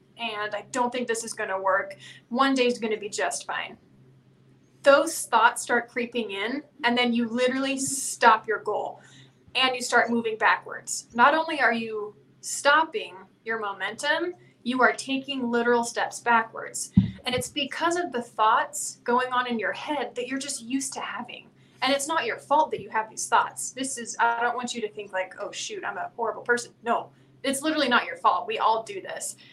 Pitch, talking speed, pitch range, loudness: 240 Hz, 195 wpm, 220-270 Hz, -25 LUFS